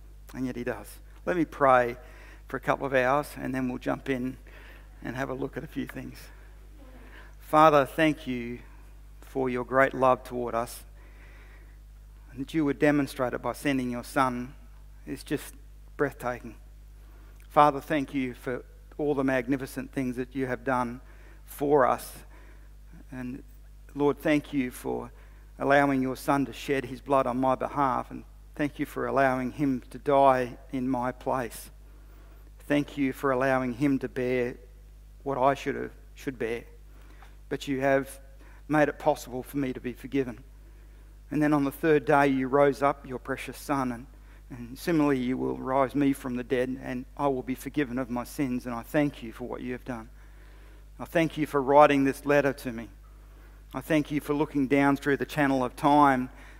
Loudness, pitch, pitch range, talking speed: -27 LUFS, 135 Hz, 125-140 Hz, 180 wpm